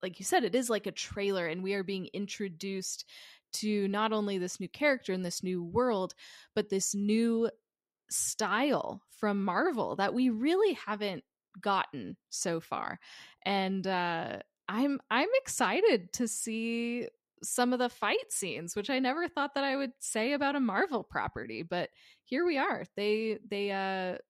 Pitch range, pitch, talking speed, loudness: 195-255 Hz, 215 Hz, 165 wpm, -32 LUFS